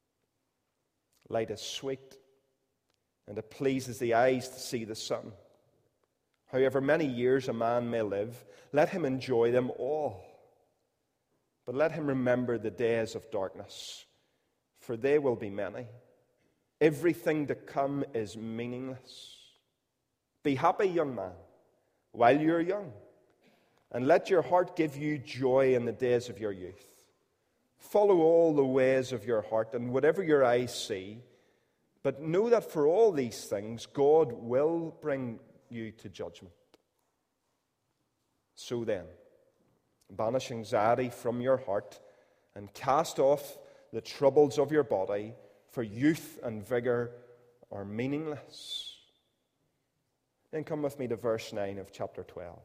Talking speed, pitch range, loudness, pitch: 135 wpm, 115-140 Hz, -30 LUFS, 125 Hz